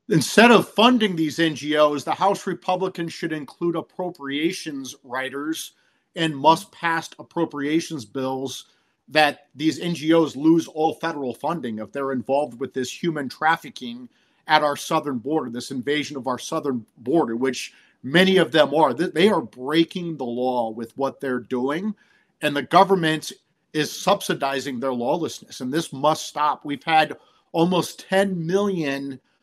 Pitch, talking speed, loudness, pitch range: 155 Hz, 145 wpm, -22 LUFS, 135-170 Hz